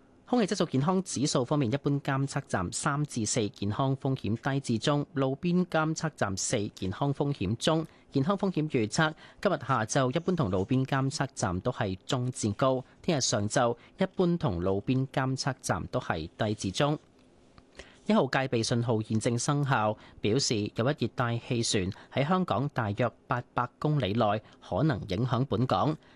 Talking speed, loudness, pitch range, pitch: 250 characters per minute, -29 LUFS, 110-145 Hz, 130 Hz